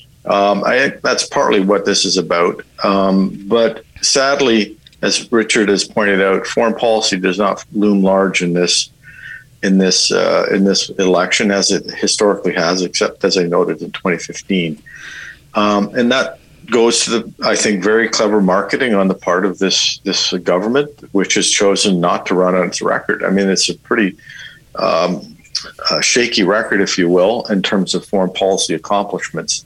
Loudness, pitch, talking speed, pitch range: -14 LUFS, 100 Hz, 175 wpm, 95-105 Hz